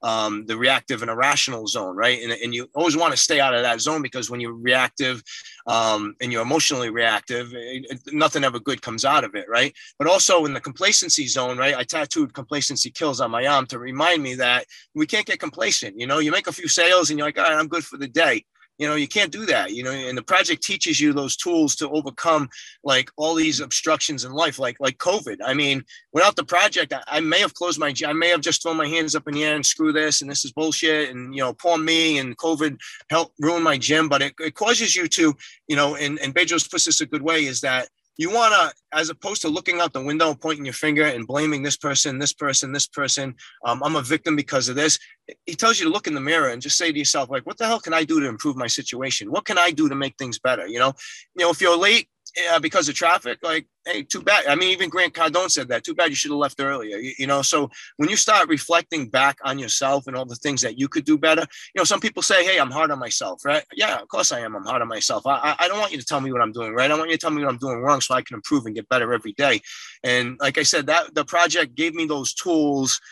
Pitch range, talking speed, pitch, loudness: 135-165 Hz, 275 wpm, 150 Hz, -20 LUFS